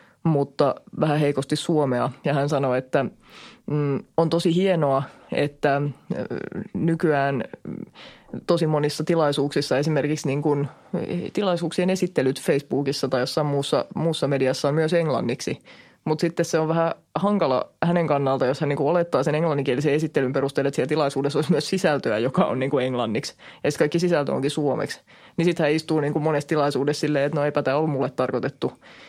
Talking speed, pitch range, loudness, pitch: 155 wpm, 140-165 Hz, -23 LUFS, 150 Hz